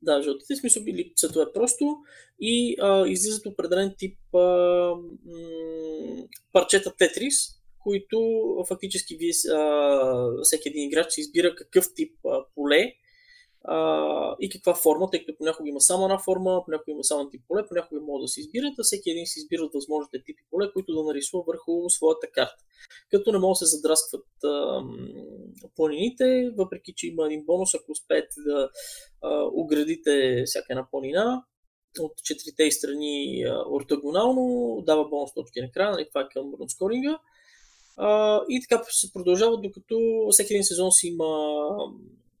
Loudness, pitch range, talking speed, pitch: -24 LUFS, 155-230 Hz, 155 wpm, 180 Hz